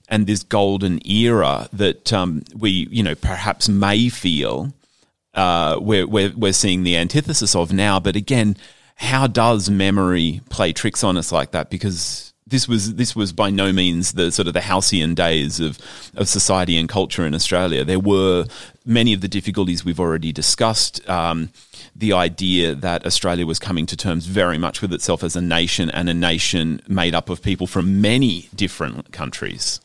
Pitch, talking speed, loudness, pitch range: 95 Hz, 180 wpm, -18 LUFS, 85-105 Hz